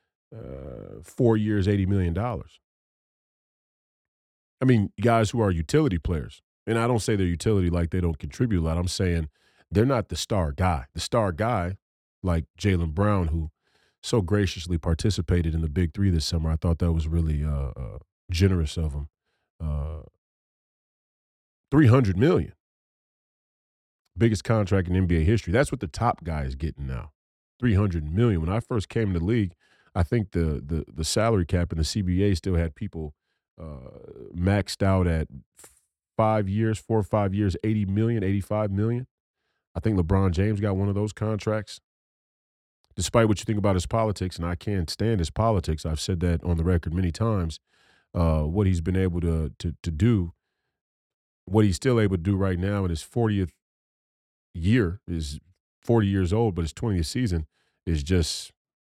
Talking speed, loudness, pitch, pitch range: 175 wpm, -25 LUFS, 90 Hz, 80-105 Hz